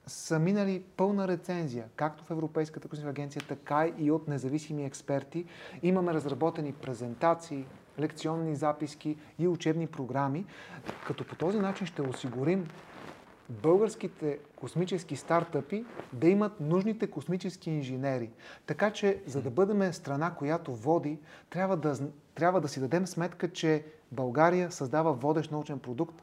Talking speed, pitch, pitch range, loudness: 130 wpm, 155 Hz, 145-175 Hz, -32 LUFS